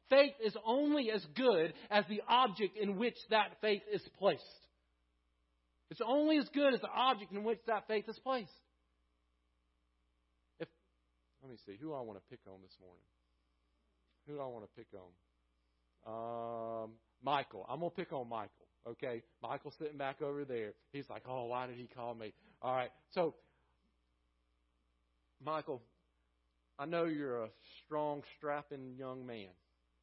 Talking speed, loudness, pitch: 160 wpm, -38 LUFS, 120 Hz